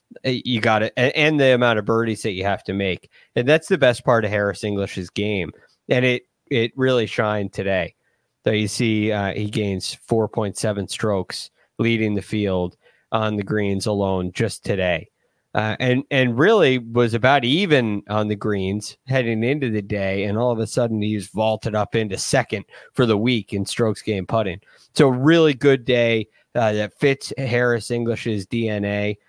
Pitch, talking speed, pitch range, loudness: 110 Hz, 175 wpm, 105-125 Hz, -21 LUFS